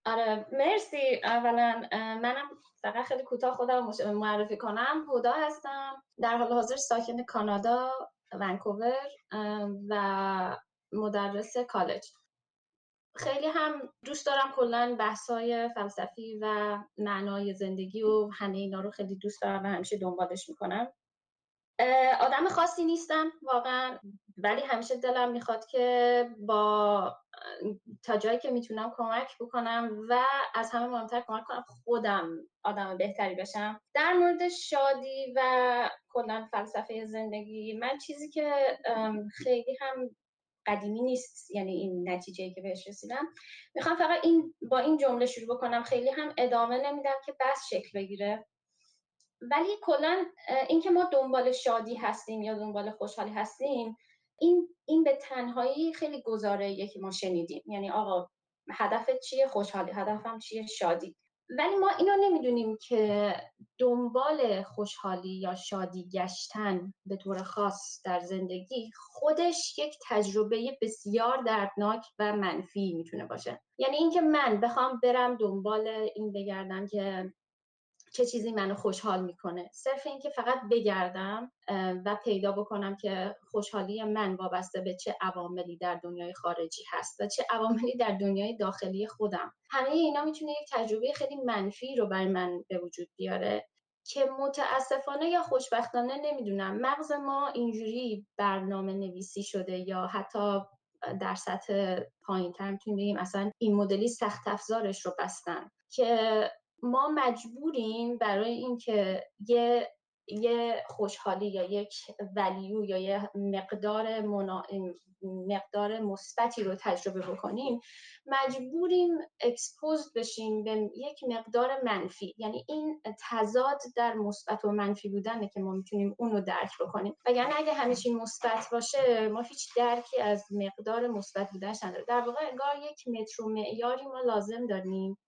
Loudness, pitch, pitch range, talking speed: -31 LUFS, 225 Hz, 200-255 Hz, 135 wpm